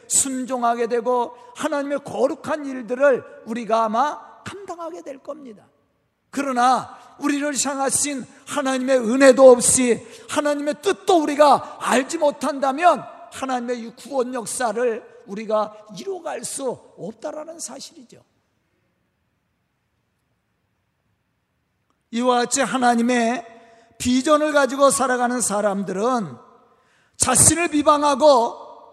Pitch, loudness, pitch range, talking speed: 265 Hz, -19 LUFS, 240-295 Hz, 240 characters per minute